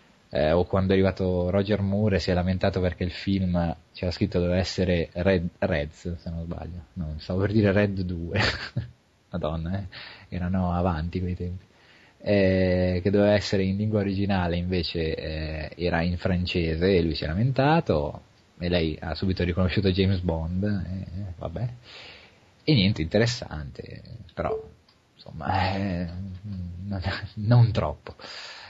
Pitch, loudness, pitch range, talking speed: 95 Hz, -26 LUFS, 85-100 Hz, 145 wpm